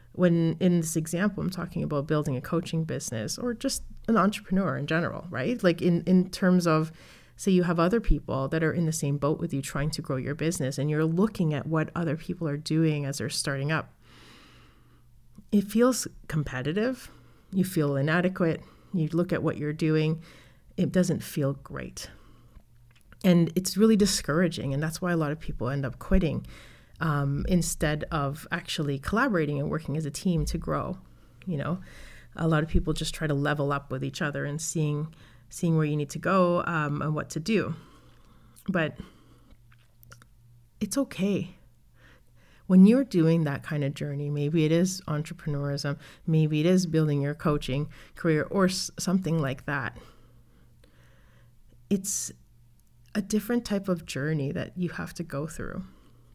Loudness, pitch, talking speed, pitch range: -27 LUFS, 155 Hz, 170 wpm, 140-175 Hz